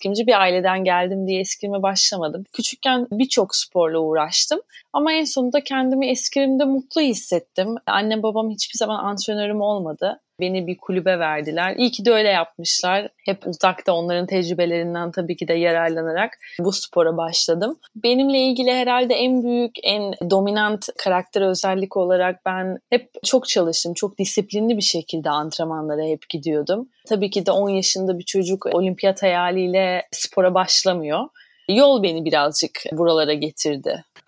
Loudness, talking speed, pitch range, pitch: -20 LUFS, 140 wpm, 175-220 Hz, 190 Hz